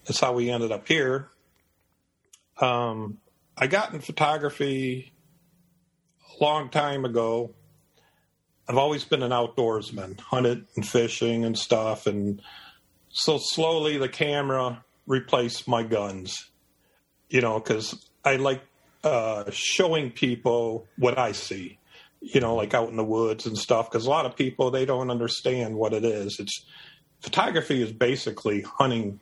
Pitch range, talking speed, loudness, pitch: 110-140 Hz, 140 wpm, -26 LUFS, 120 Hz